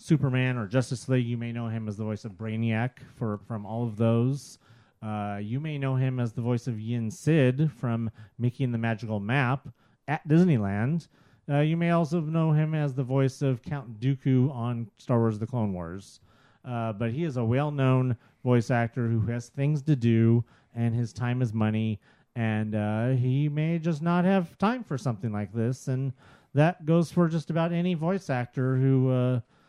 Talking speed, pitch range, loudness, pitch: 195 wpm, 115-145 Hz, -27 LUFS, 125 Hz